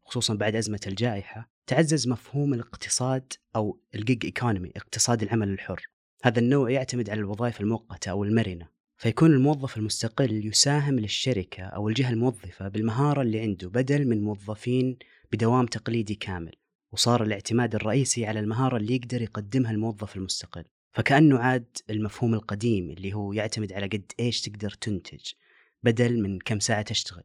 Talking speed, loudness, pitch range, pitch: 145 wpm, -26 LUFS, 105-125 Hz, 115 Hz